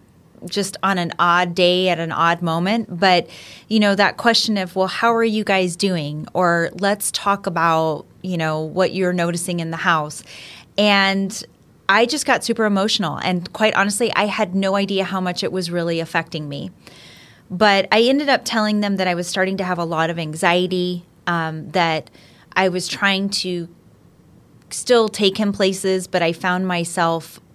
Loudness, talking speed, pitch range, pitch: -19 LUFS, 180 wpm, 170-200 Hz, 185 Hz